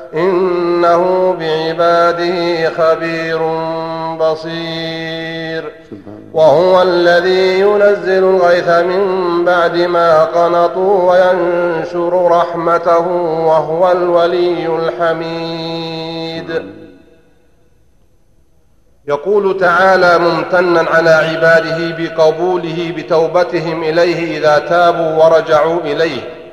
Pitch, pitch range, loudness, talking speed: 170 Hz, 160-175 Hz, -12 LUFS, 65 wpm